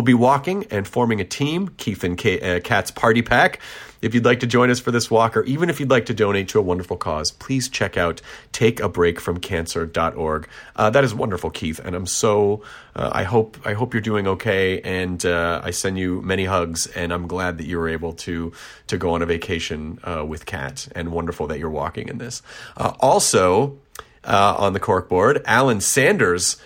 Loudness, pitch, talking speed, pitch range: -20 LUFS, 95 Hz, 210 wpm, 85-120 Hz